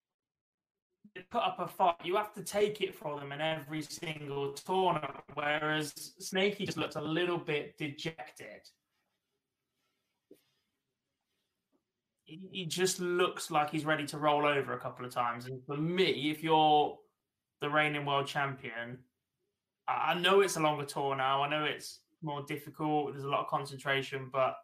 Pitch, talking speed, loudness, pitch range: 150 Hz, 155 wpm, -33 LUFS, 140-175 Hz